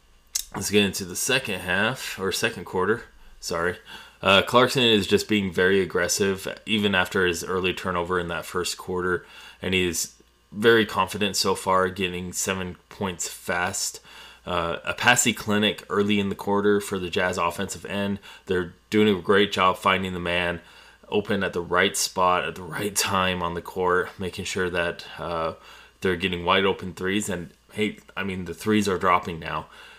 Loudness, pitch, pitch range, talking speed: -24 LUFS, 95 Hz, 90-105 Hz, 175 wpm